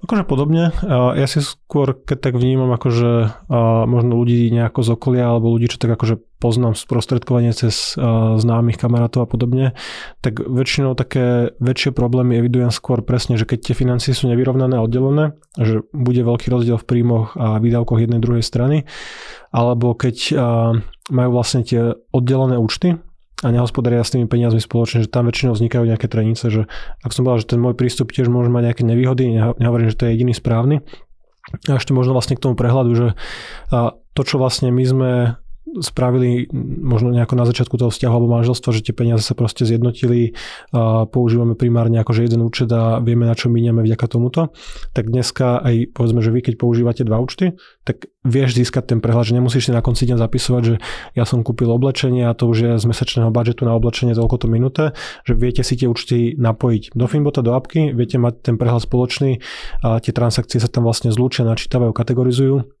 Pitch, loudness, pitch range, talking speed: 120 Hz, -17 LUFS, 115-125 Hz, 185 wpm